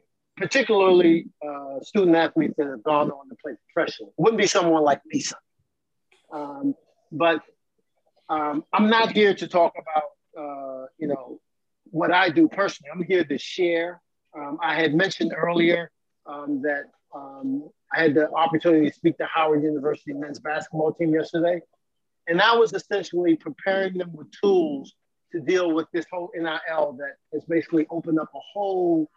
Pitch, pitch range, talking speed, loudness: 165 Hz, 150-185 Hz, 160 wpm, -23 LUFS